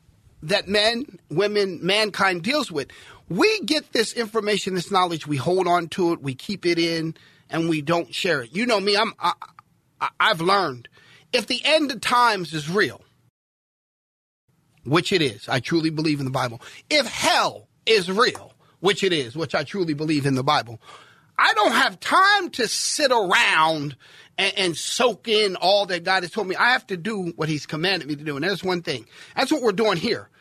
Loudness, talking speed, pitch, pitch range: -21 LUFS, 195 wpm, 185 Hz, 160-220 Hz